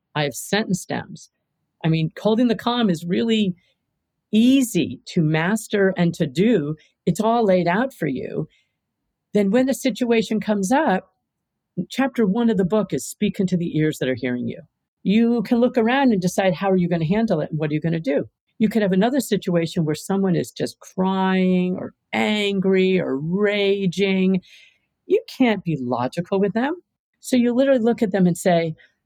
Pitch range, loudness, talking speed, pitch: 170-225 Hz, -21 LUFS, 190 wpm, 195 Hz